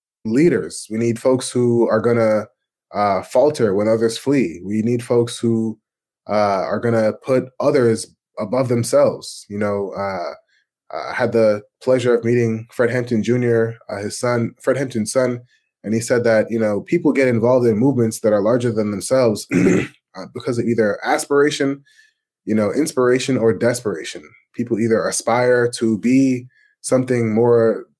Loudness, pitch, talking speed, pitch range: -18 LUFS, 115 Hz, 160 wpm, 110-125 Hz